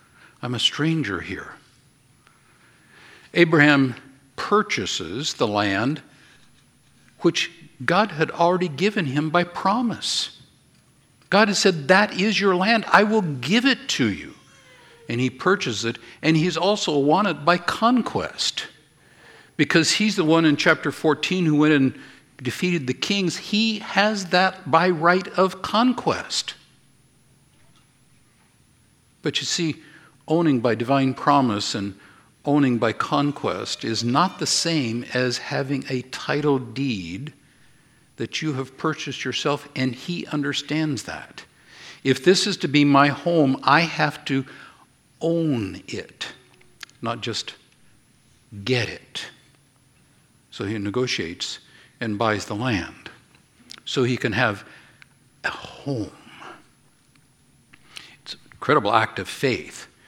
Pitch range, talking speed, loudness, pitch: 130-180 Hz, 125 wpm, -22 LUFS, 150 Hz